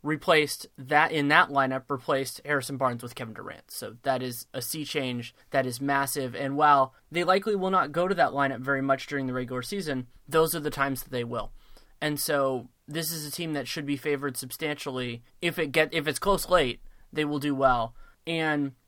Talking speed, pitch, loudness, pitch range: 210 wpm, 140 Hz, -27 LUFS, 130-155 Hz